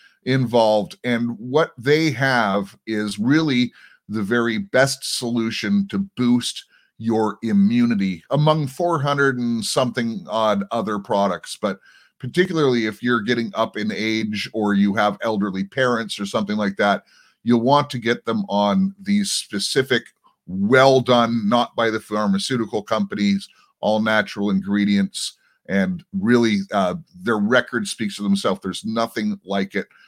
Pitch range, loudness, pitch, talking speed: 105-140 Hz, -20 LUFS, 115 Hz, 140 wpm